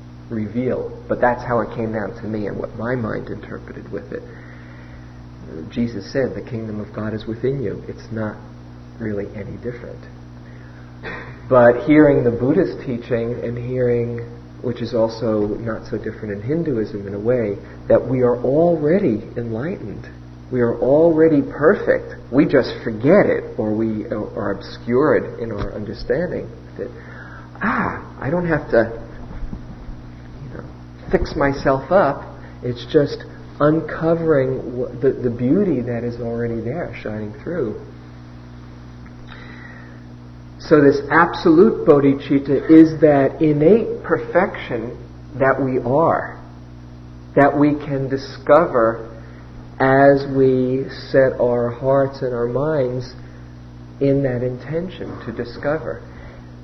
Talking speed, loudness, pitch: 125 wpm, -18 LUFS, 115 Hz